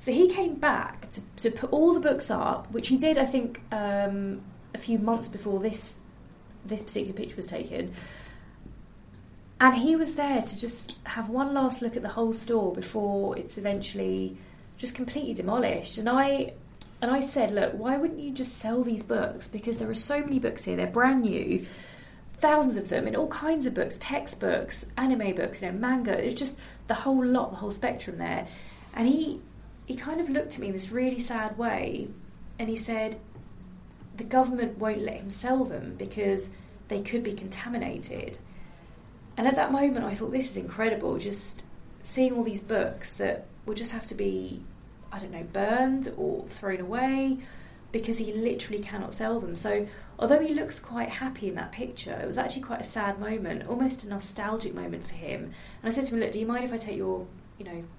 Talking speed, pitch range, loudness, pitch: 200 wpm, 205-260 Hz, -29 LUFS, 230 Hz